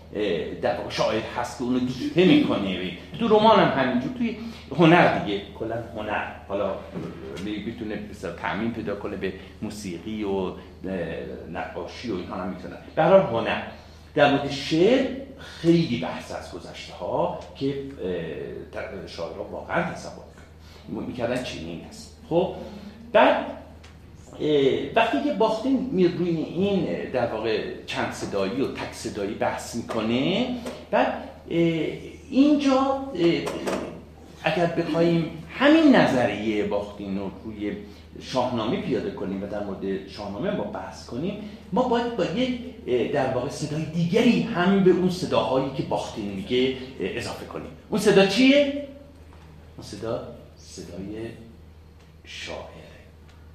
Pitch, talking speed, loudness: 120 Hz, 120 wpm, -24 LUFS